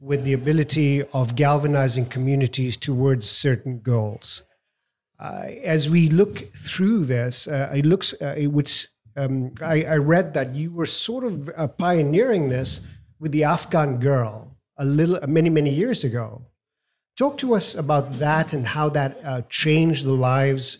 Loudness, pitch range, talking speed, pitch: -21 LUFS, 130-155 Hz, 160 wpm, 140 Hz